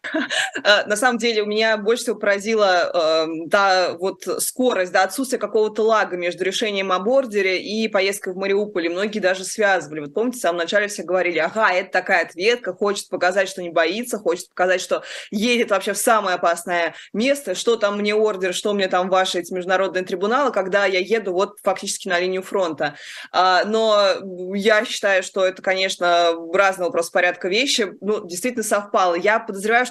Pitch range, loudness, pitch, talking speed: 185-215 Hz, -20 LUFS, 195 Hz, 175 wpm